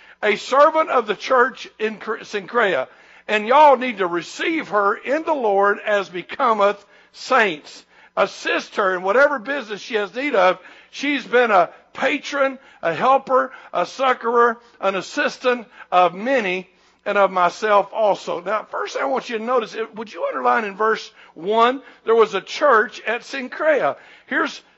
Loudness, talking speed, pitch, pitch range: -19 LUFS, 155 wpm, 230 Hz, 205-265 Hz